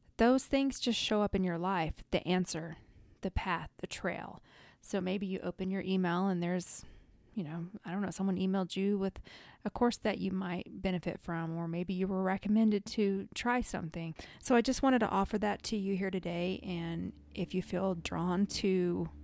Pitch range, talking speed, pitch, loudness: 175-205 Hz, 195 wpm, 190 Hz, -34 LUFS